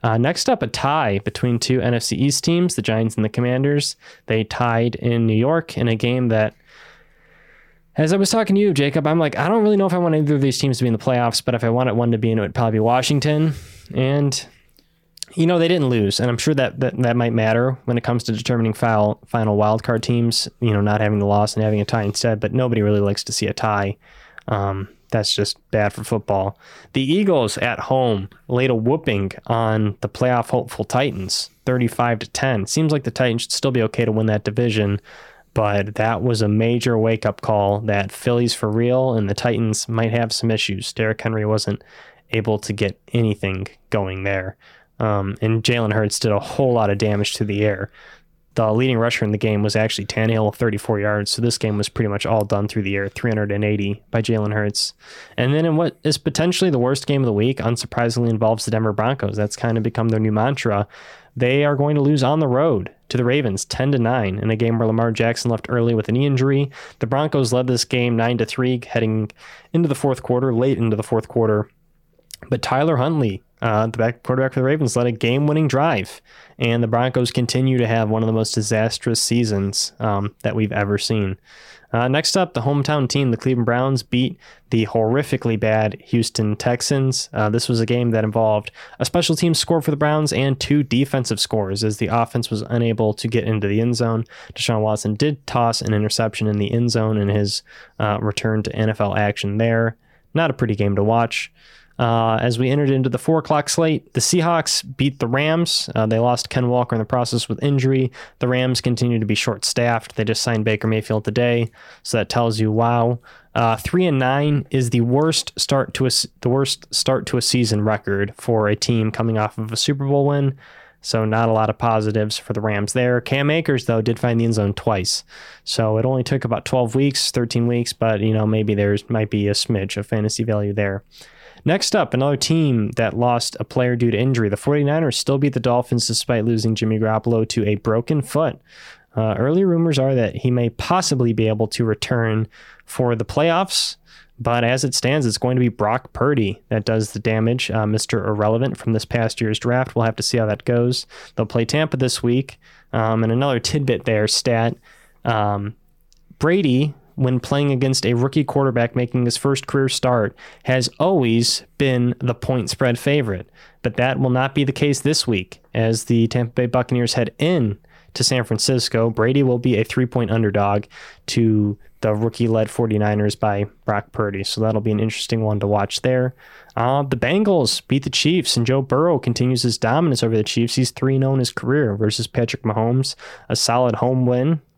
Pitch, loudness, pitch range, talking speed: 120 Hz, -19 LUFS, 110-130 Hz, 210 wpm